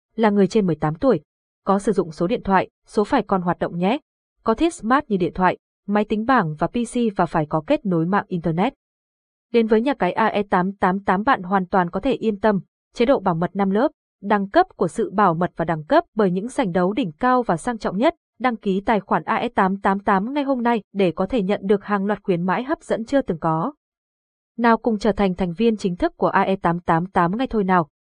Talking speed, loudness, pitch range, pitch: 230 wpm, -21 LUFS, 185-235 Hz, 205 Hz